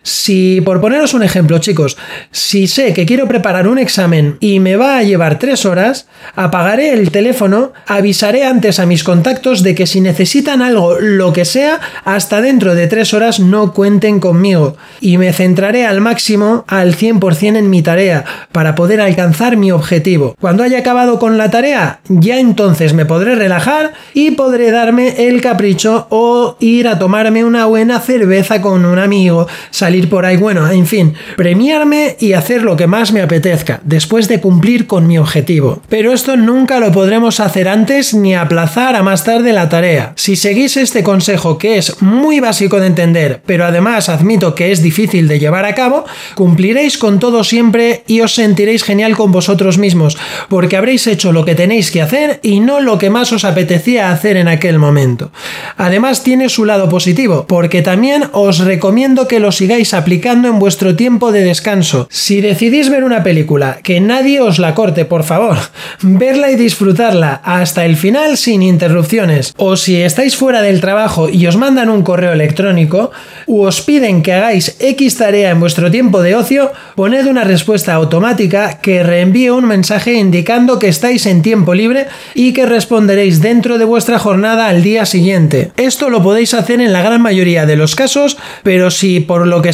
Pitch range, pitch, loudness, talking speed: 180-235 Hz, 200 Hz, -9 LUFS, 180 wpm